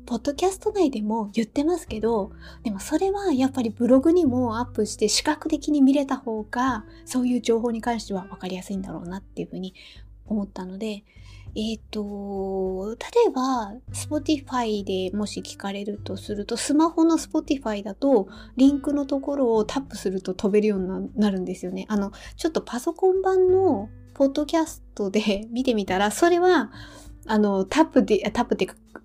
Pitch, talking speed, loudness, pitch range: 225 Hz, 380 characters per minute, -24 LUFS, 200-285 Hz